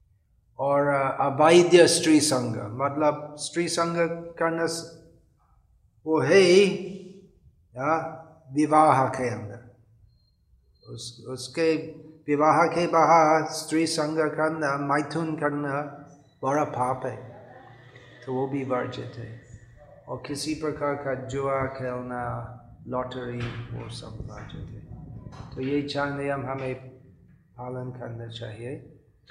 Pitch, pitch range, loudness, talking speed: 140 Hz, 125-155 Hz, -24 LUFS, 100 wpm